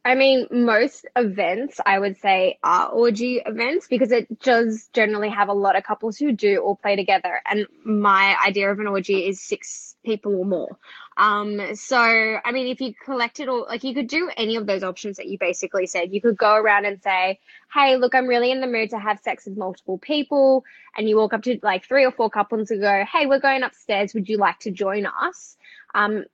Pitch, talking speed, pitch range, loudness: 220 Hz, 225 wpm, 200-250 Hz, -21 LUFS